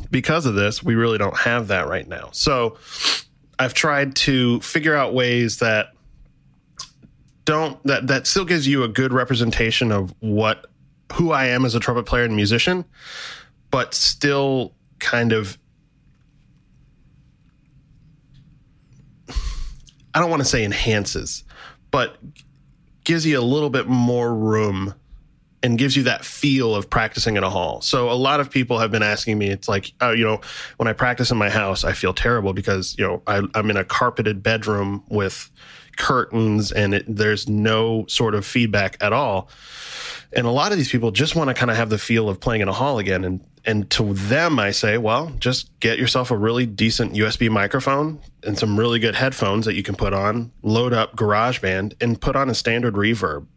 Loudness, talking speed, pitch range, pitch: -20 LUFS, 180 wpm, 105-135 Hz, 115 Hz